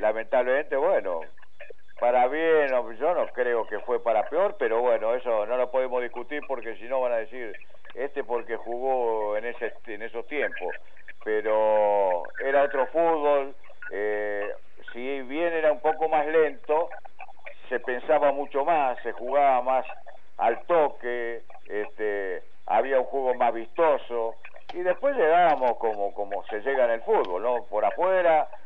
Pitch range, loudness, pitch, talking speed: 115-155 Hz, -26 LUFS, 130 Hz, 150 wpm